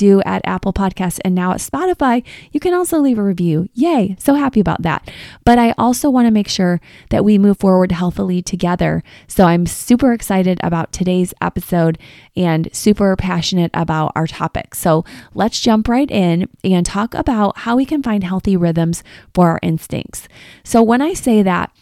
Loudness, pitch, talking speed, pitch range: -15 LUFS, 190 Hz, 185 wpm, 175-235 Hz